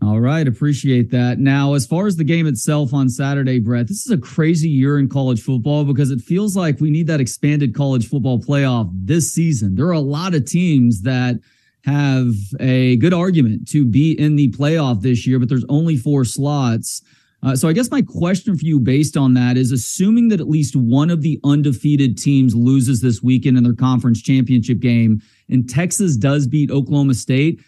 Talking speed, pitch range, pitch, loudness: 200 wpm, 125-150 Hz, 140 Hz, -16 LUFS